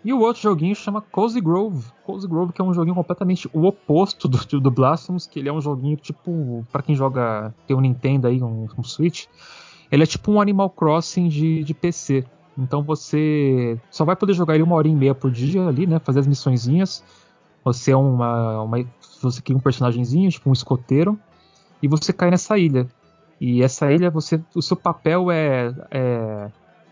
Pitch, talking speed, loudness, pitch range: 150 Hz, 190 wpm, -20 LUFS, 130-175 Hz